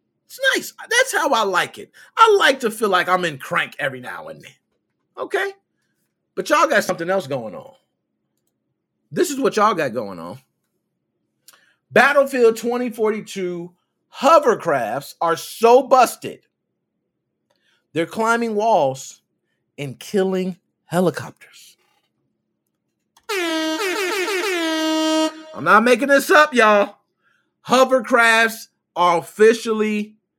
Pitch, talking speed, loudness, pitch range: 230 Hz, 110 wpm, -18 LUFS, 190-310 Hz